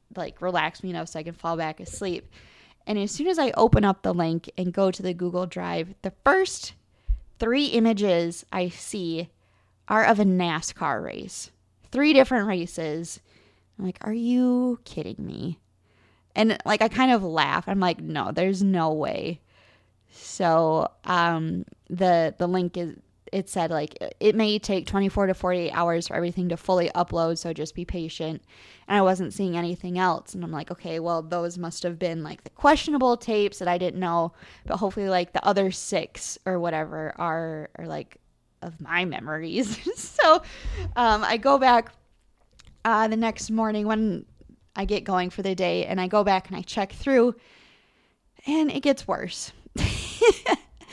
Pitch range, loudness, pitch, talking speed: 170-215 Hz, -25 LUFS, 185 Hz, 175 wpm